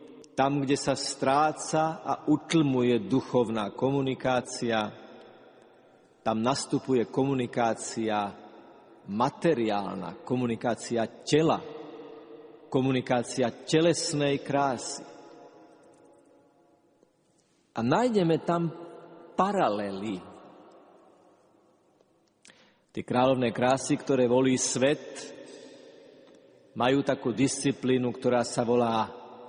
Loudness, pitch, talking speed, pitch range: -27 LUFS, 130 Hz, 65 wpm, 120-150 Hz